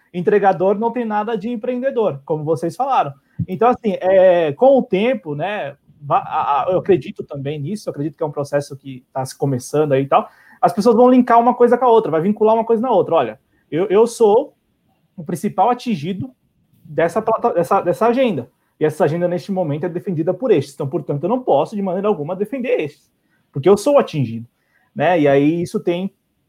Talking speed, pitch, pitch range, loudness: 200 wpm, 195 Hz, 160-240 Hz, -17 LUFS